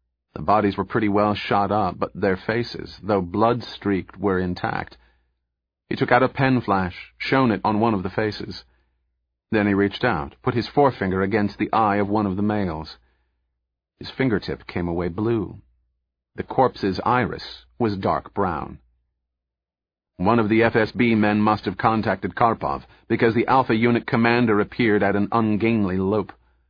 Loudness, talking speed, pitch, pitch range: -22 LUFS, 160 wpm, 100 Hz, 65-110 Hz